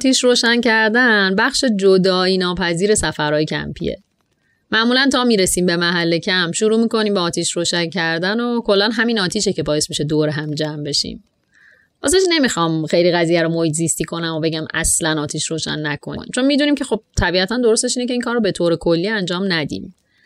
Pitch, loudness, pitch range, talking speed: 185 Hz, -17 LUFS, 165-225 Hz, 180 wpm